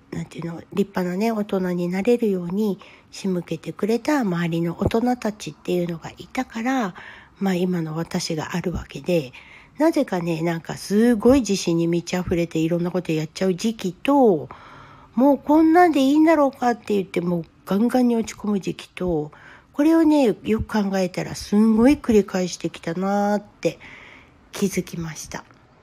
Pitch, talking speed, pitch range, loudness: 190 Hz, 350 characters per minute, 170-230 Hz, -22 LUFS